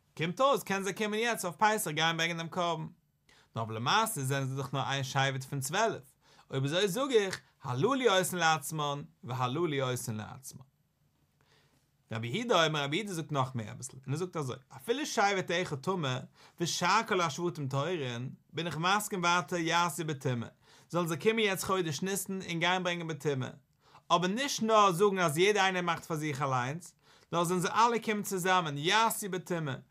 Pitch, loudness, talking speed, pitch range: 165 Hz, -31 LUFS, 195 wpm, 140-190 Hz